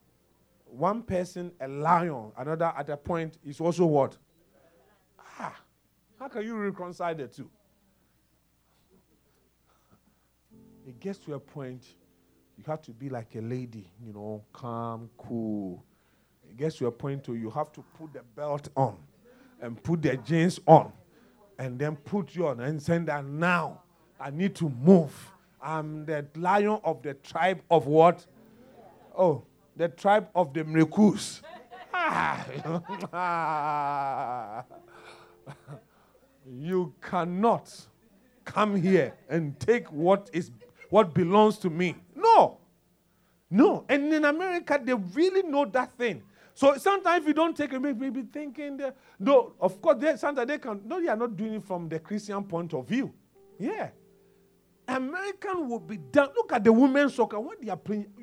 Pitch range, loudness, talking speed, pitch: 145-215 Hz, -27 LUFS, 150 wpm, 175 Hz